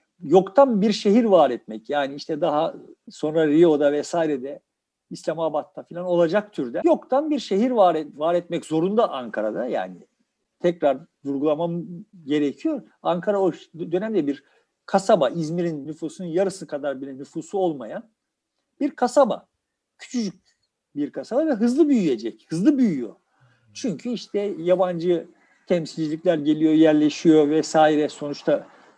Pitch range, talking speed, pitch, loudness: 155-220 Hz, 120 wpm, 175 Hz, -22 LUFS